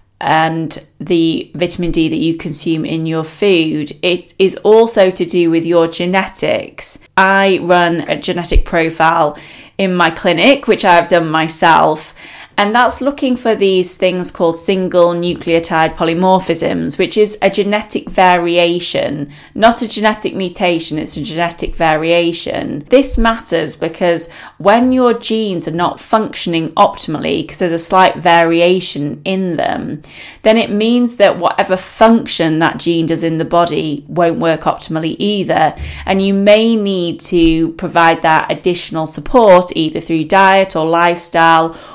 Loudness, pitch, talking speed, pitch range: -13 LUFS, 175 Hz, 145 wpm, 165-195 Hz